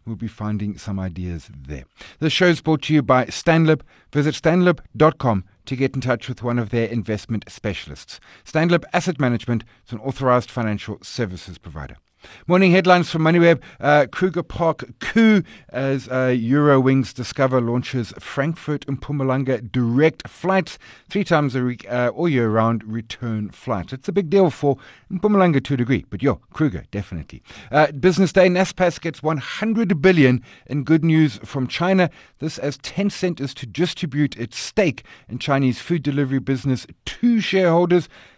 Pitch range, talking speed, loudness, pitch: 120-165 Hz, 160 wpm, -20 LUFS, 135 Hz